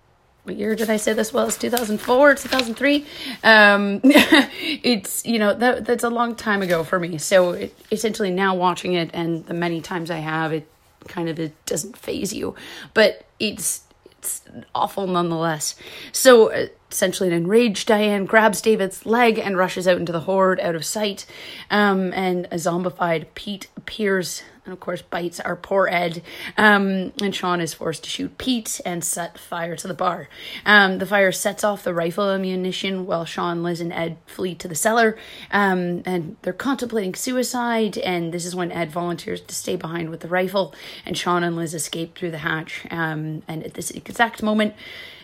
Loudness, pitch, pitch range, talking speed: -21 LUFS, 185 Hz, 170-215 Hz, 185 wpm